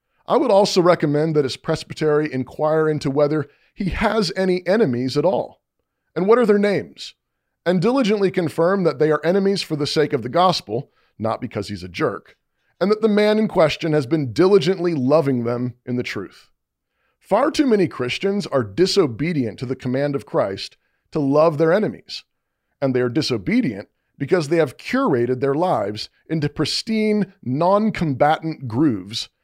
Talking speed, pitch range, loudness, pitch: 170 wpm, 135-190 Hz, -20 LUFS, 155 Hz